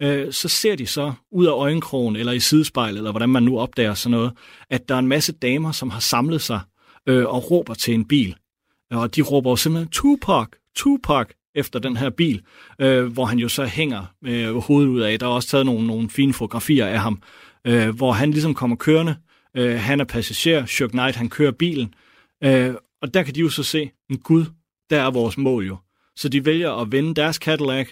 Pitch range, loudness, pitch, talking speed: 120-150 Hz, -20 LUFS, 130 Hz, 205 wpm